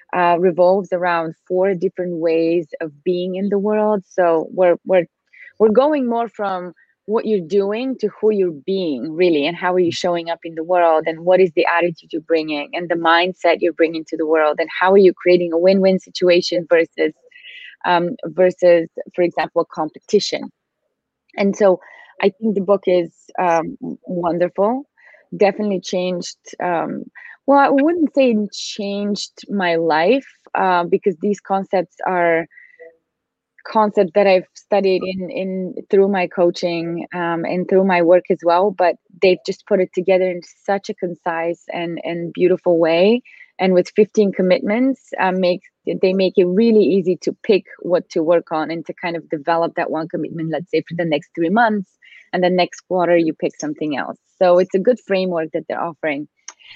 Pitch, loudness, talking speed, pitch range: 180 Hz, -18 LUFS, 175 wpm, 170-200 Hz